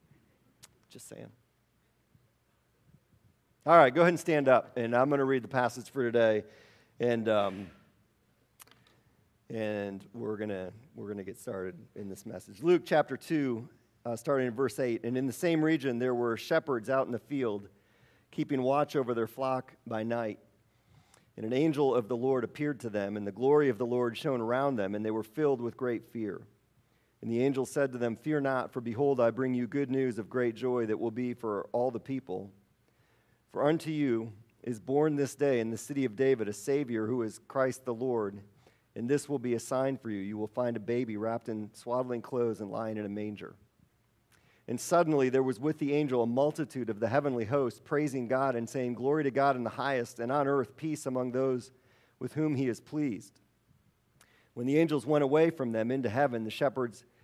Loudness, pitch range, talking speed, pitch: -31 LUFS, 115-140 Hz, 205 wpm, 125 Hz